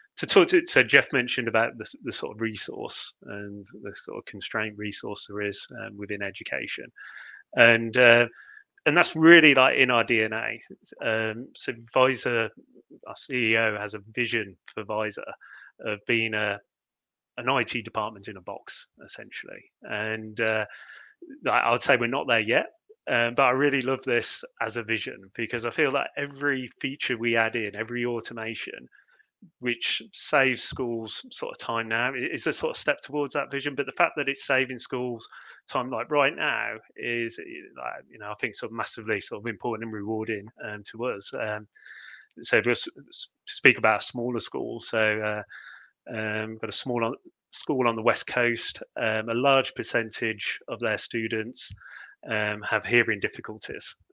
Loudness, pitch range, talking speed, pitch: -25 LUFS, 110-130 Hz, 170 wpm, 115 Hz